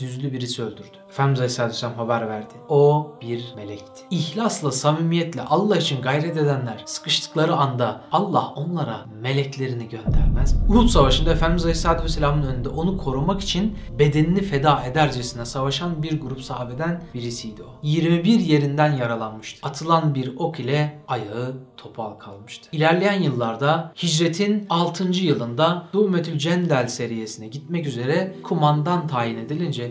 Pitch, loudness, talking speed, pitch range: 150 Hz, -22 LUFS, 130 wpm, 125-165 Hz